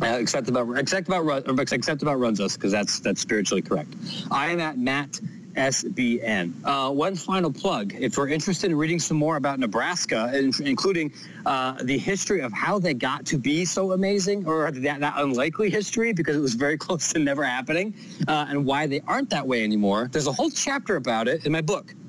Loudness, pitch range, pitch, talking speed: -24 LUFS, 140-190 Hz, 155 Hz, 200 wpm